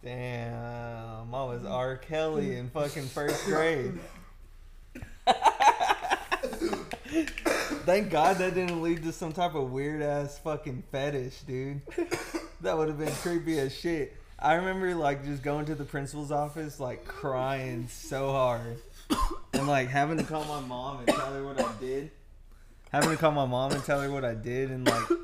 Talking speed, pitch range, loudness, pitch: 165 wpm, 130-165 Hz, -30 LUFS, 145 Hz